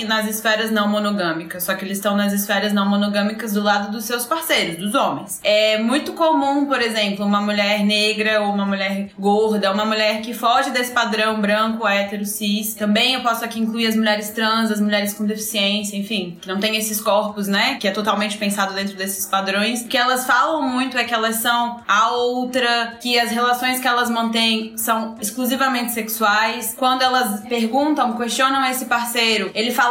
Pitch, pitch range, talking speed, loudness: 220 Hz, 205-240 Hz, 190 wpm, -19 LUFS